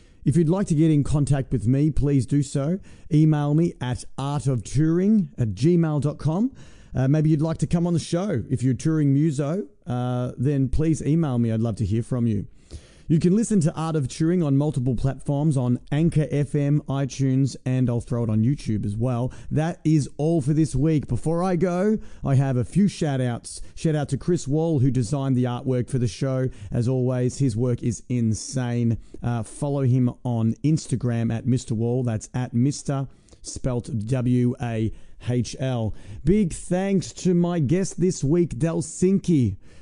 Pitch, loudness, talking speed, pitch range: 135 Hz, -23 LUFS, 180 wpm, 125-160 Hz